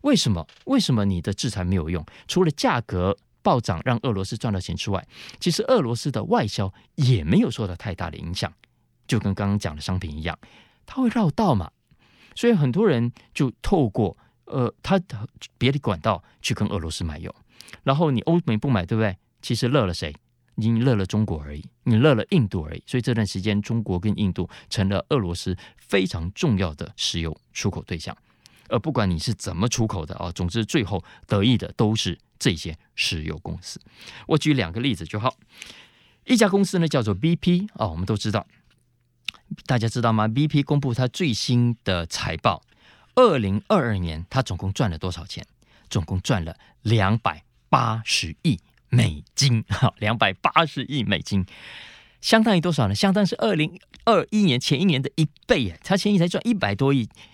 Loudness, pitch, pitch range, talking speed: -23 LUFS, 115 Hz, 95-135 Hz, 280 characters per minute